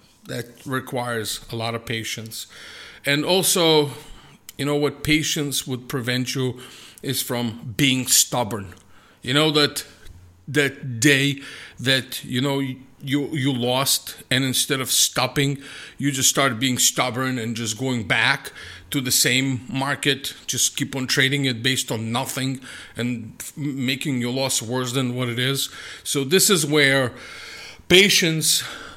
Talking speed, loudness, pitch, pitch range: 145 wpm, -21 LUFS, 130 Hz, 125-145 Hz